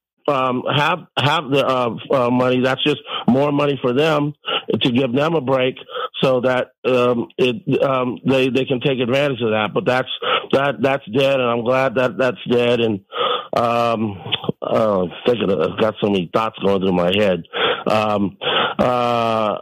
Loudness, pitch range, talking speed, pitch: -18 LUFS, 115-135 Hz, 175 wpm, 125 Hz